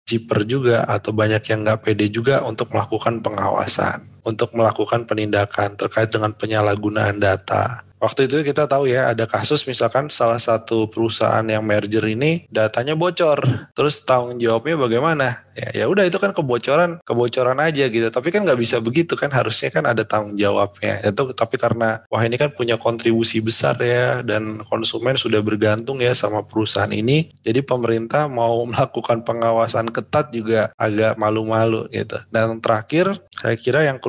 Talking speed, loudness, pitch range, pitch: 160 wpm, -19 LUFS, 110-125 Hz, 115 Hz